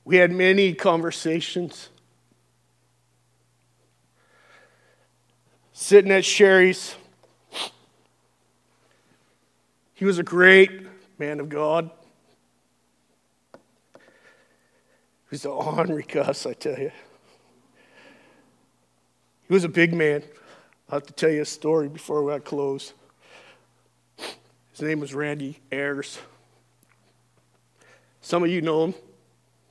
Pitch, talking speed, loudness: 150 Hz, 95 wpm, -21 LUFS